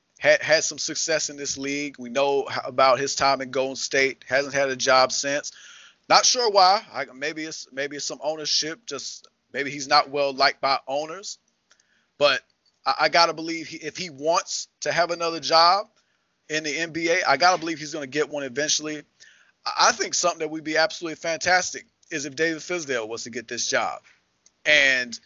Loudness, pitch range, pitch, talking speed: -23 LUFS, 140-165 Hz, 150 Hz, 190 wpm